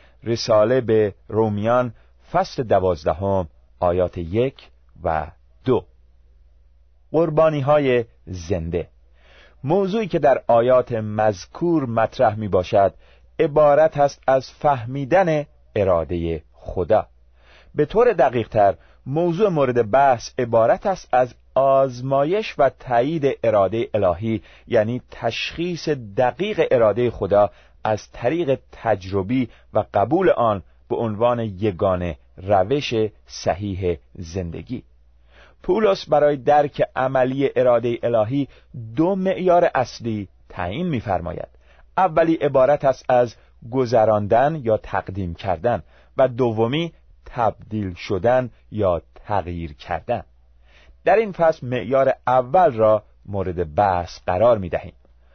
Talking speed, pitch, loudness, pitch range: 100 wpm, 115 Hz, -20 LUFS, 90-135 Hz